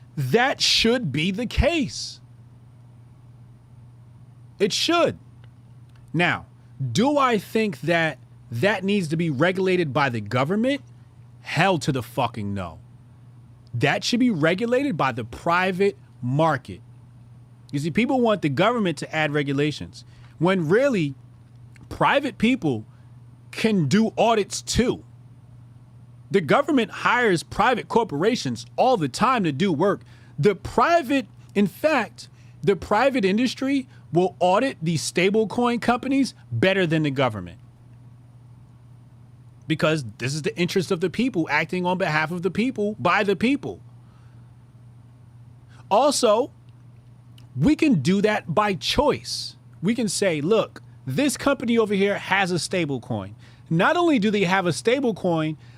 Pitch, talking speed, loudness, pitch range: 150 Hz, 130 wpm, -22 LUFS, 120-200 Hz